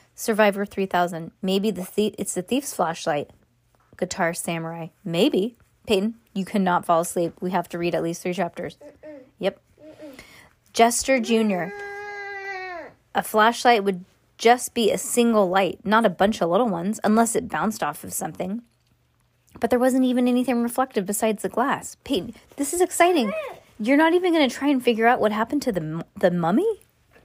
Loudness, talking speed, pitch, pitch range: -23 LUFS, 170 wpm, 220 Hz, 190-260 Hz